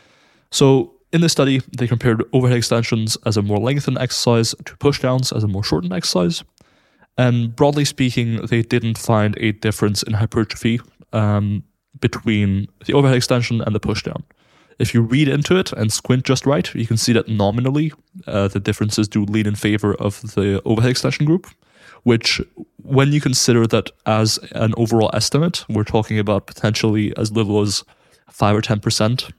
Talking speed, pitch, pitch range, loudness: 170 wpm, 115 Hz, 105-130 Hz, -18 LUFS